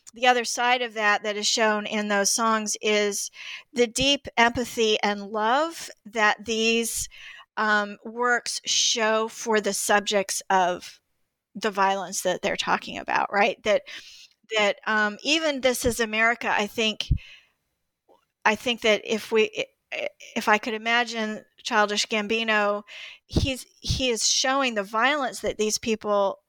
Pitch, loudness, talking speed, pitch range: 220 Hz, -24 LUFS, 140 wpm, 210-240 Hz